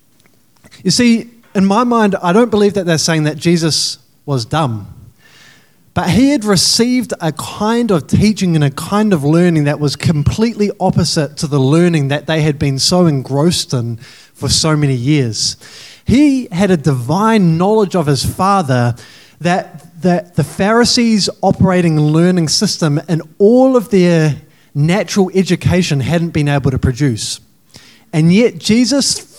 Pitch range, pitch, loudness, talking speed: 145-200 Hz, 170 Hz, -13 LUFS, 155 wpm